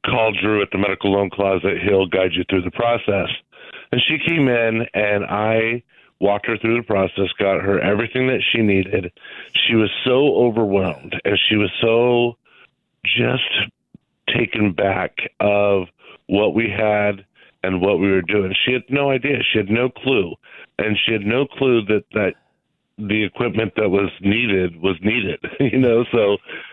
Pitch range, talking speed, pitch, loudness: 100-120 Hz, 170 wpm, 105 Hz, -18 LUFS